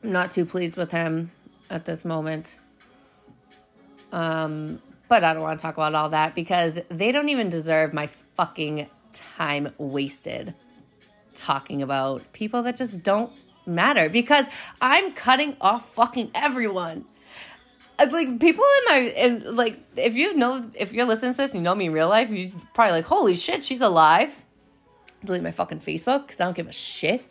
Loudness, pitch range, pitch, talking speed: -23 LUFS, 160-245 Hz, 185 Hz, 175 wpm